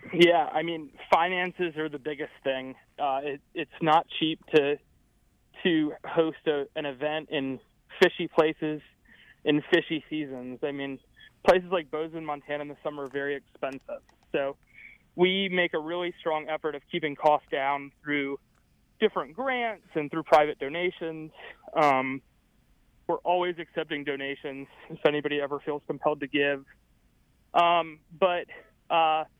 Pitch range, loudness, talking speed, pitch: 145-170 Hz, -28 LUFS, 145 wpm, 155 Hz